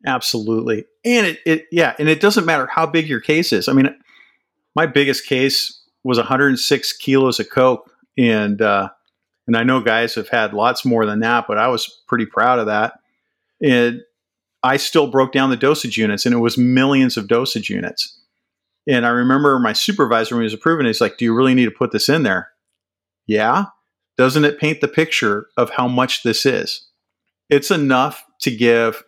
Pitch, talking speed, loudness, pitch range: 130 Hz, 195 wpm, -16 LUFS, 115-145 Hz